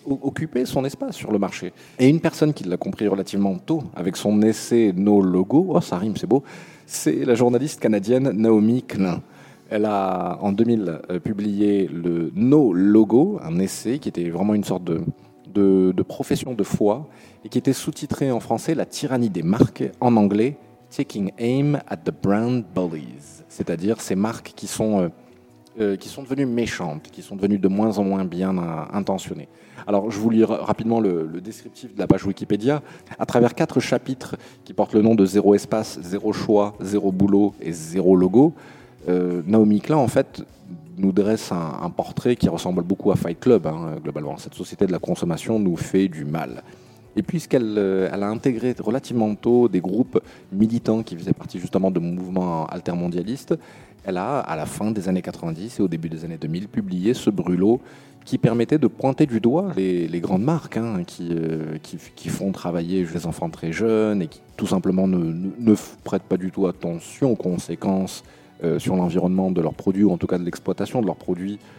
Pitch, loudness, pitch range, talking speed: 105 Hz, -22 LUFS, 95-120 Hz, 195 wpm